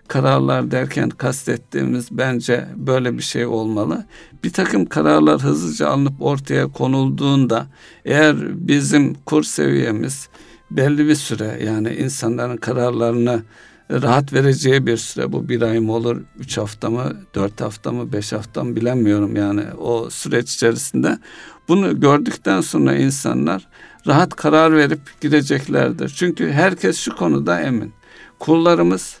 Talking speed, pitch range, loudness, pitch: 125 wpm, 105-135 Hz, -18 LUFS, 120 Hz